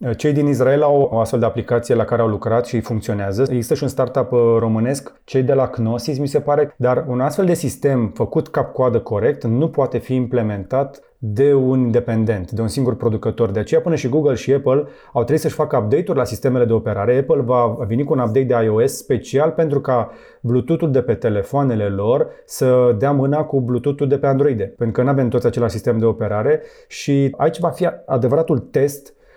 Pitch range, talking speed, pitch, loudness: 115-145 Hz, 205 wpm, 125 Hz, -18 LUFS